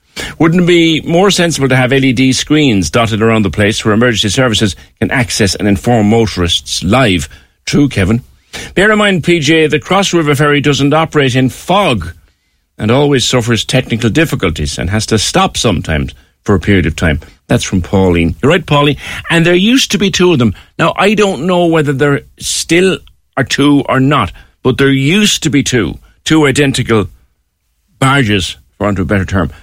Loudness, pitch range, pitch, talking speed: -11 LUFS, 95-150 Hz, 125 Hz, 185 wpm